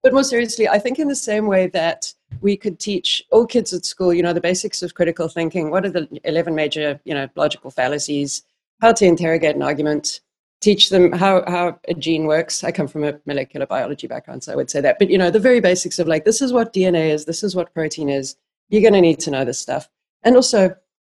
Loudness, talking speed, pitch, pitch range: -18 LUFS, 240 wpm, 175 Hz, 155-205 Hz